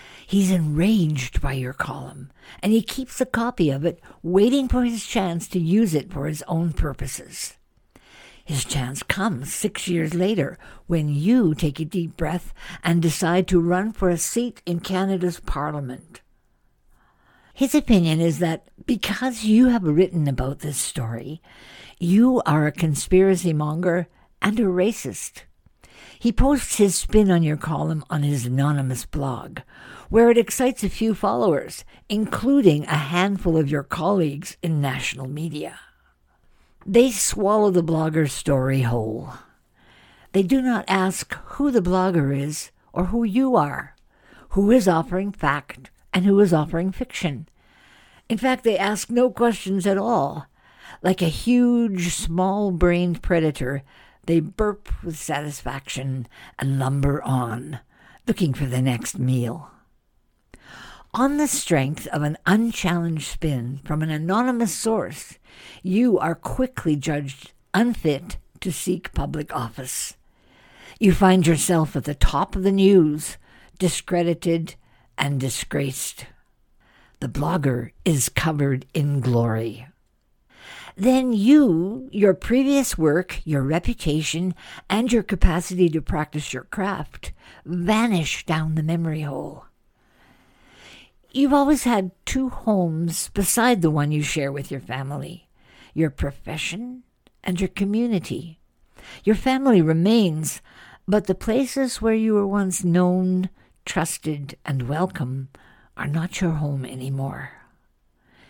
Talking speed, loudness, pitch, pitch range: 130 wpm, -22 LUFS, 175 Hz, 150-205 Hz